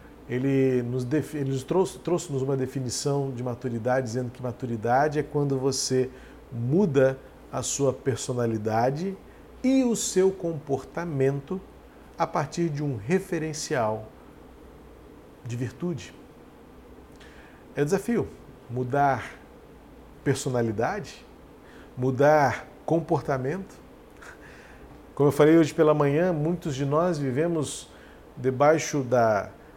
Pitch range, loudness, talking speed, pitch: 130-155 Hz, -26 LUFS, 95 wpm, 140 Hz